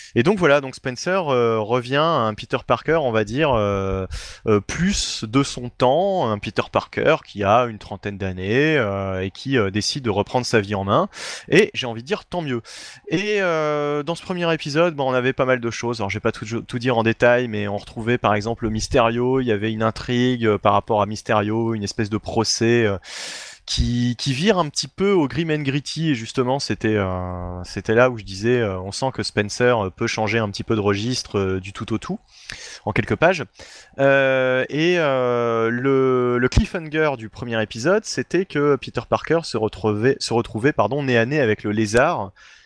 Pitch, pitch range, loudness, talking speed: 120 Hz, 110-135 Hz, -21 LUFS, 210 wpm